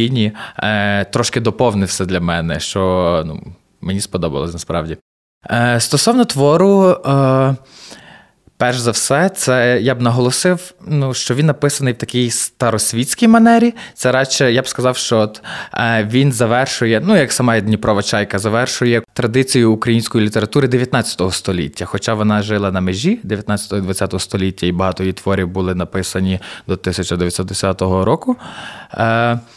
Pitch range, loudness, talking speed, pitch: 95-130 Hz, -15 LUFS, 125 wpm, 115 Hz